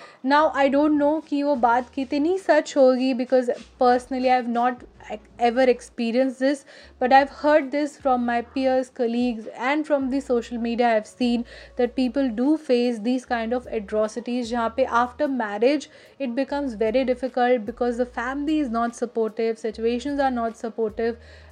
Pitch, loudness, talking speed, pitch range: 255 Hz, -23 LUFS, 165 wpm, 235-275 Hz